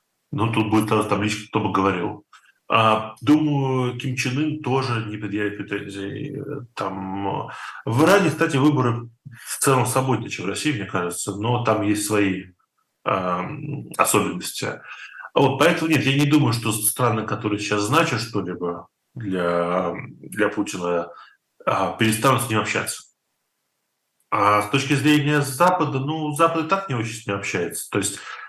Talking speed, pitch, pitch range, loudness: 145 wpm, 115 Hz, 105-140 Hz, -22 LUFS